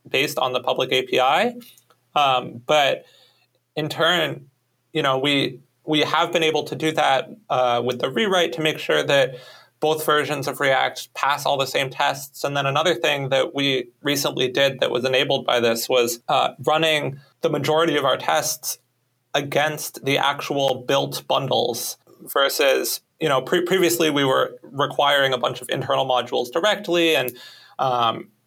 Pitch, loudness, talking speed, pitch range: 145 Hz, -21 LUFS, 165 wpm, 135-160 Hz